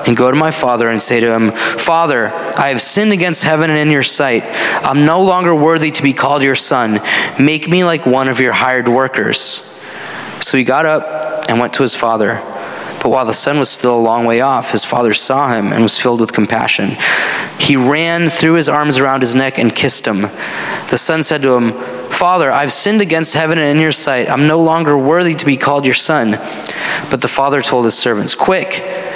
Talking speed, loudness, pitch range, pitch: 215 wpm, -11 LUFS, 125-160 Hz, 140 Hz